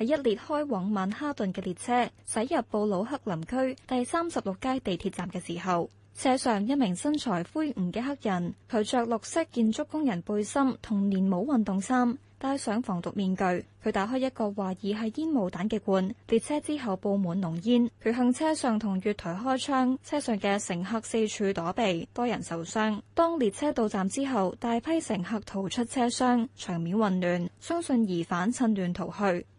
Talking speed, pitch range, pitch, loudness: 270 characters per minute, 190-255 Hz, 220 Hz, -29 LUFS